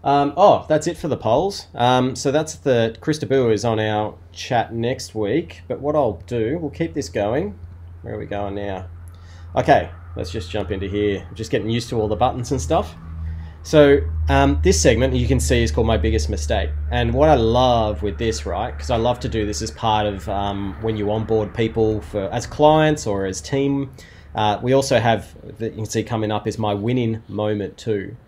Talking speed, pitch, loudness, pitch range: 215 wpm, 110 Hz, -20 LUFS, 95-125 Hz